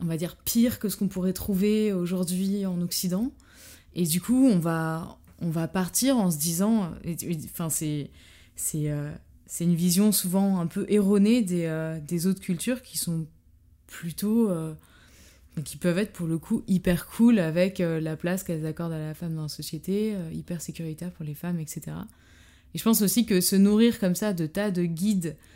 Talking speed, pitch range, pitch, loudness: 200 wpm, 160-200 Hz, 175 Hz, -26 LUFS